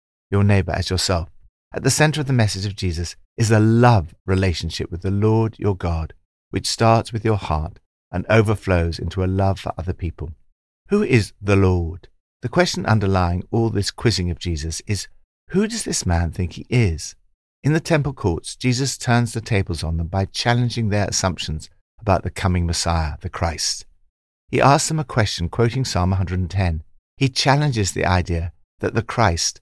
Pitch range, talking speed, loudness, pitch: 85-115 Hz, 180 wpm, -20 LUFS, 95 Hz